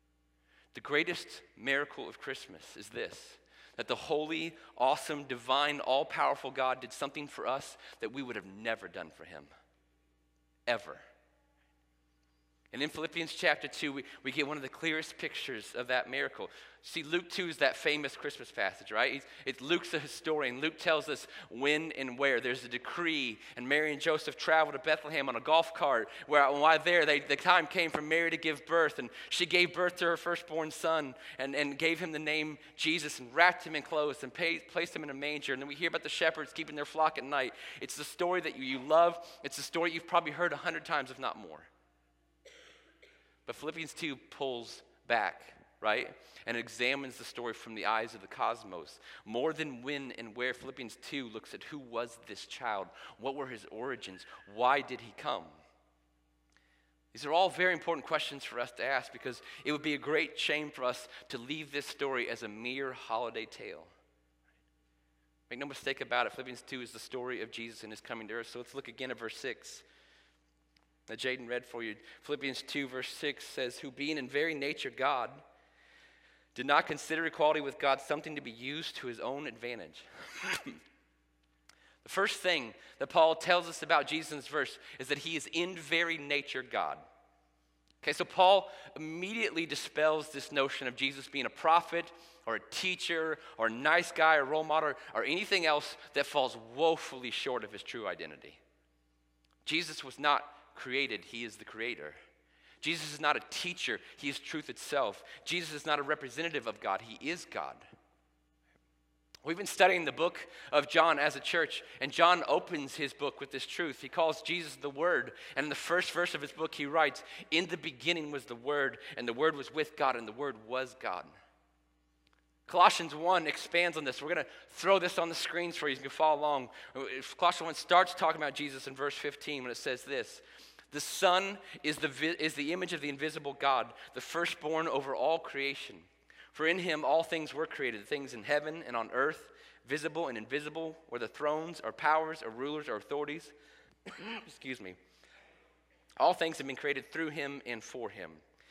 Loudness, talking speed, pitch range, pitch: -33 LUFS, 195 wpm, 125-160 Hz, 145 Hz